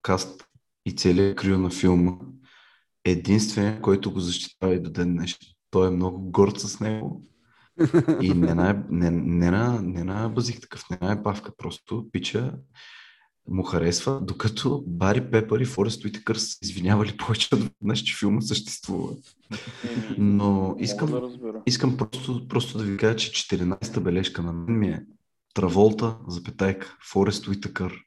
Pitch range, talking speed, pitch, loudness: 90-110 Hz, 145 wpm, 100 Hz, -25 LUFS